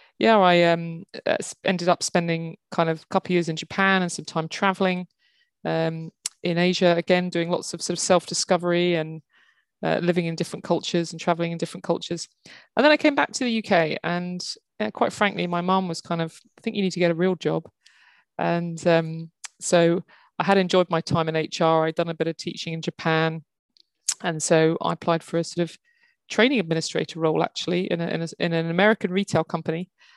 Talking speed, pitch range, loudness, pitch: 210 wpm, 165-185 Hz, -23 LUFS, 175 Hz